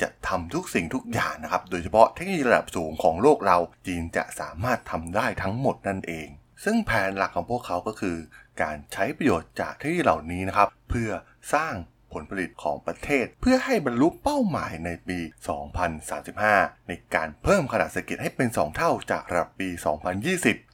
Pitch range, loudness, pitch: 85-120 Hz, -26 LUFS, 95 Hz